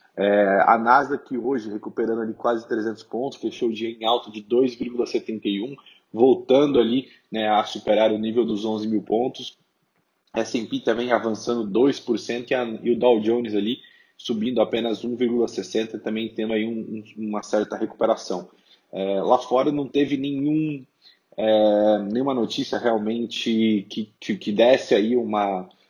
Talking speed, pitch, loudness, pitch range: 155 wpm, 115 Hz, -23 LUFS, 110-120 Hz